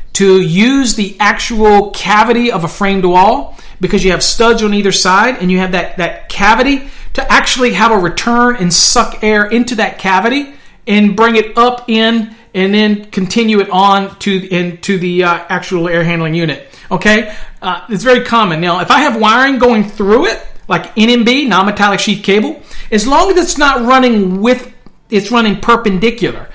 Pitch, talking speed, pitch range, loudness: 210 Hz, 180 wpm, 190-235 Hz, -10 LUFS